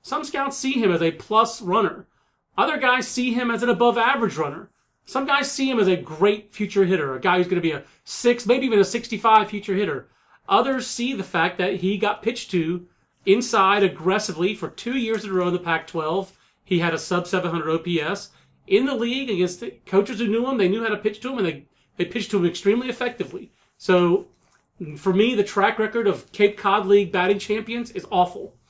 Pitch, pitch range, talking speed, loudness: 205 Hz, 180-235 Hz, 220 wpm, -22 LUFS